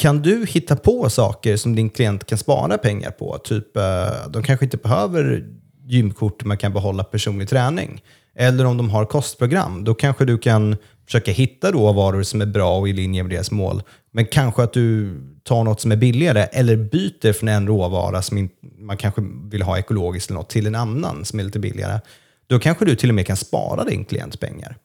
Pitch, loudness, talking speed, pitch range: 110 Hz, -19 LUFS, 200 wpm, 105-125 Hz